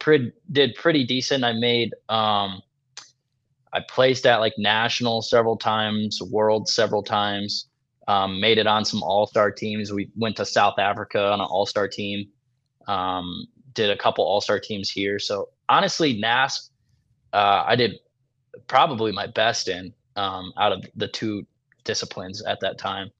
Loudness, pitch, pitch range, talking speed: -22 LUFS, 110 Hz, 100-130 Hz, 160 wpm